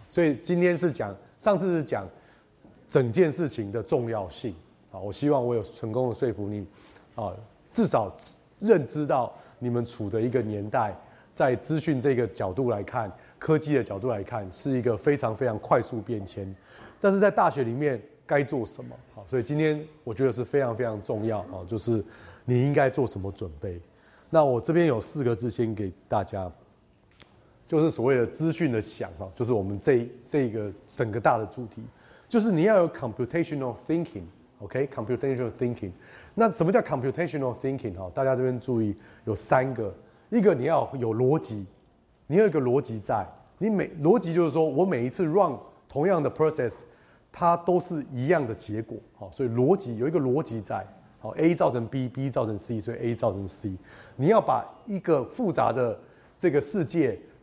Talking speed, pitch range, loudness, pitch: 340 characters per minute, 110-150 Hz, -27 LUFS, 125 Hz